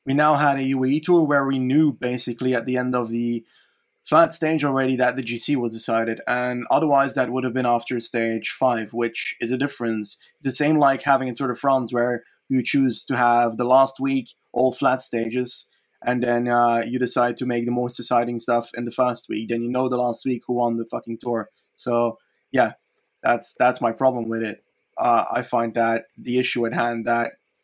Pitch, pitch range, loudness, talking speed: 125 Hz, 120-130 Hz, -22 LUFS, 215 wpm